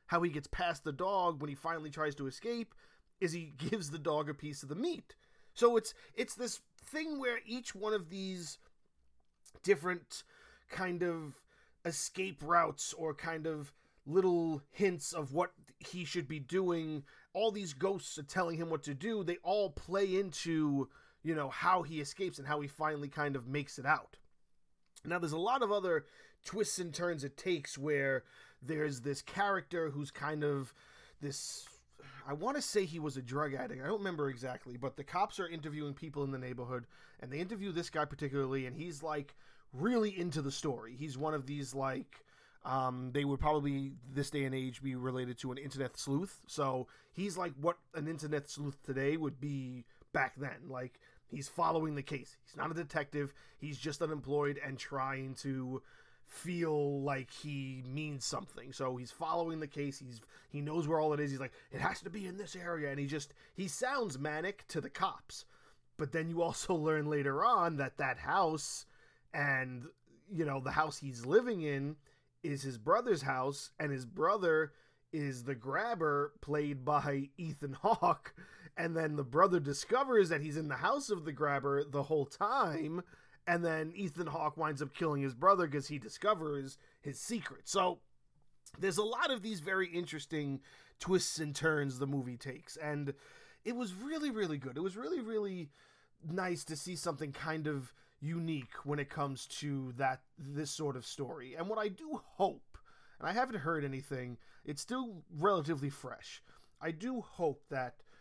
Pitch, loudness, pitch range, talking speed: 150 Hz, -37 LUFS, 140-175 Hz, 185 wpm